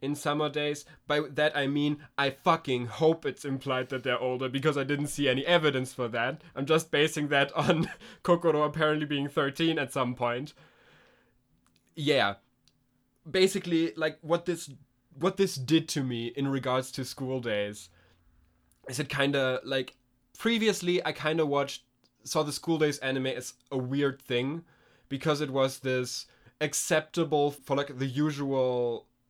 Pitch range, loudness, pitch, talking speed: 130-155 Hz, -29 LUFS, 140 Hz, 155 wpm